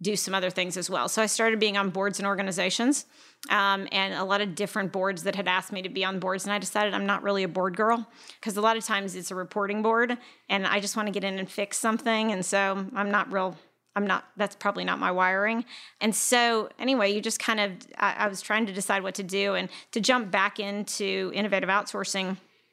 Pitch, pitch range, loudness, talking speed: 200 Hz, 190-215 Hz, -27 LUFS, 245 wpm